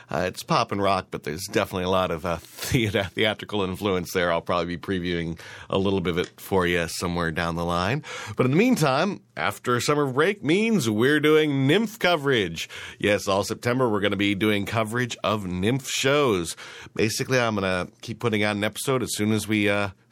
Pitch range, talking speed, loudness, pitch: 90-120 Hz, 205 wpm, -24 LUFS, 100 Hz